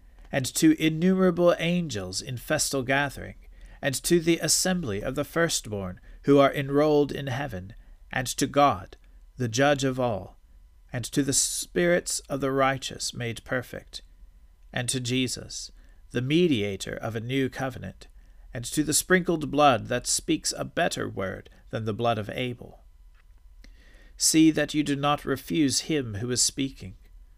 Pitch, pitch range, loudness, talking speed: 125 Hz, 95-145 Hz, -25 LUFS, 150 wpm